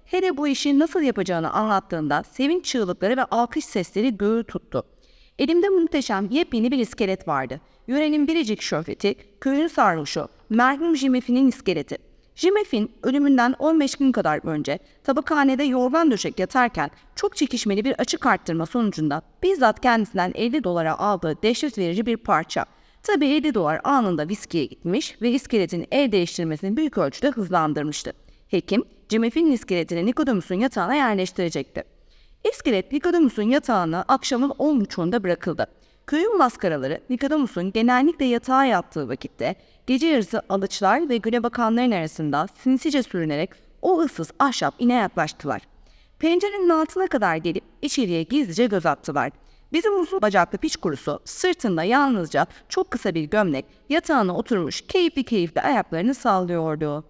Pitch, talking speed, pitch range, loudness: 240 Hz, 130 wpm, 185-285 Hz, -22 LUFS